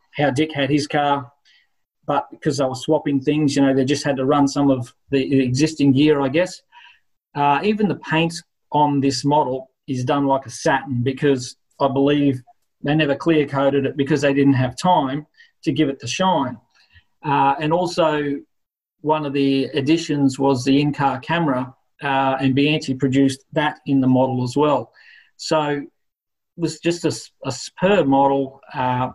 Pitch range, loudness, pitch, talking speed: 135-155 Hz, -19 LUFS, 140 Hz, 175 wpm